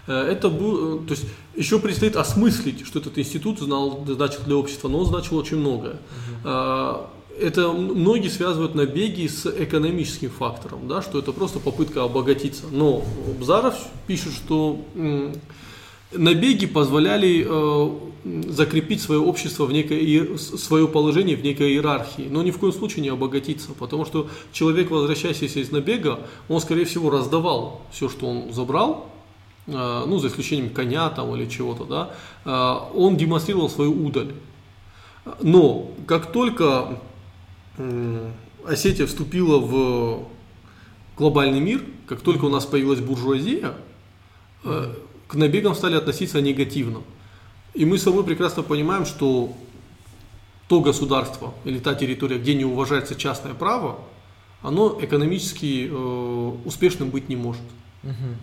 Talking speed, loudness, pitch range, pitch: 125 wpm, -22 LUFS, 125-160 Hz, 145 Hz